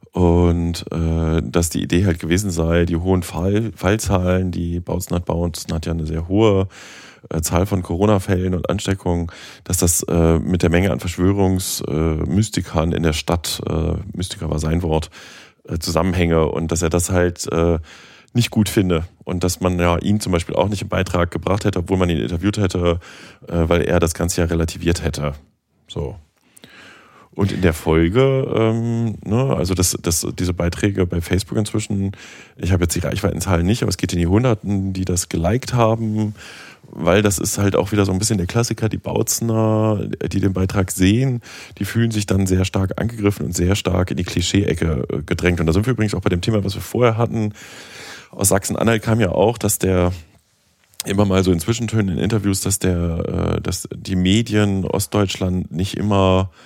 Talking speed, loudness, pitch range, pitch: 190 wpm, -19 LUFS, 85-105 Hz, 95 Hz